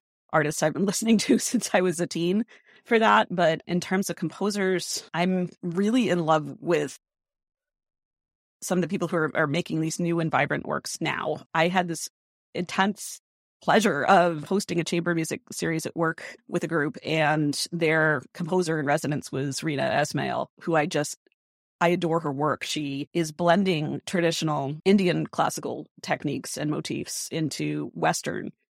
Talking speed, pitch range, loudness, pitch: 165 wpm, 155-185 Hz, -25 LUFS, 170 Hz